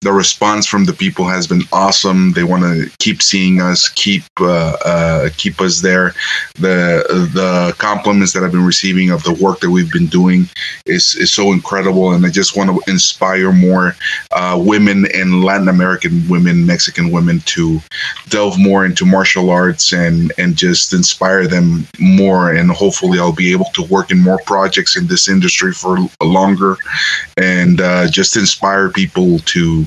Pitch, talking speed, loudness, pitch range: 95 Hz, 175 wpm, -11 LUFS, 90-105 Hz